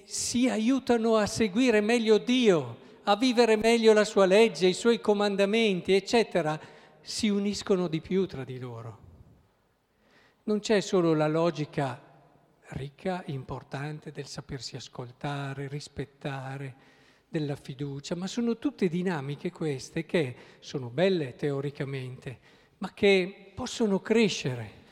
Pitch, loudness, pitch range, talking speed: 170 Hz, -27 LUFS, 140-210 Hz, 120 wpm